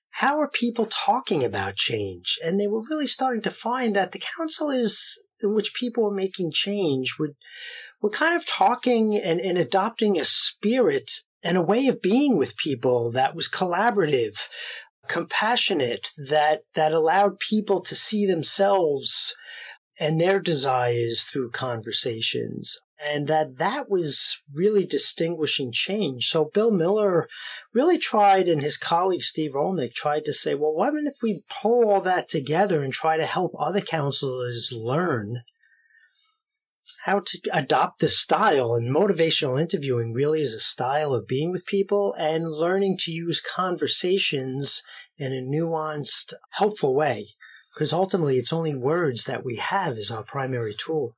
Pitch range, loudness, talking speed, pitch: 150-215 Hz, -23 LUFS, 150 wpm, 180 Hz